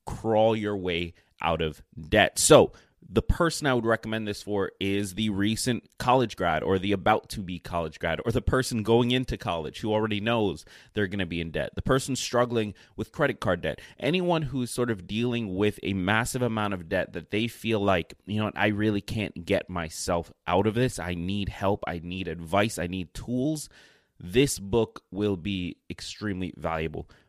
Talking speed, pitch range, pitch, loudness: 195 wpm, 90-115 Hz, 105 Hz, -27 LUFS